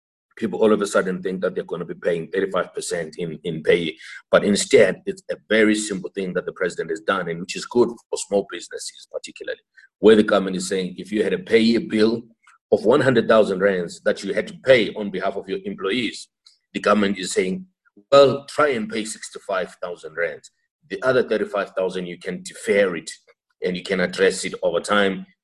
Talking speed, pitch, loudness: 200 wpm, 260 Hz, -21 LUFS